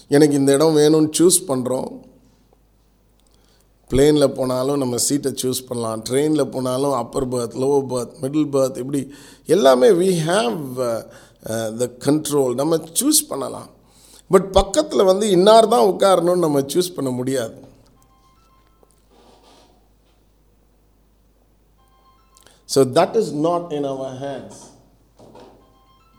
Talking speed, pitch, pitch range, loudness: 105 wpm, 140 Hz, 130-160 Hz, -18 LUFS